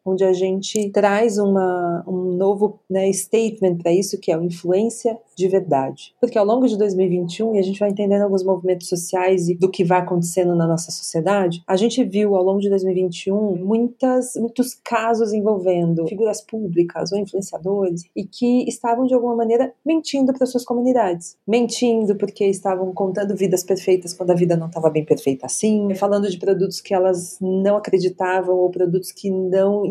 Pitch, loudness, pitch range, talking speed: 195 Hz, -19 LUFS, 185-215 Hz, 180 wpm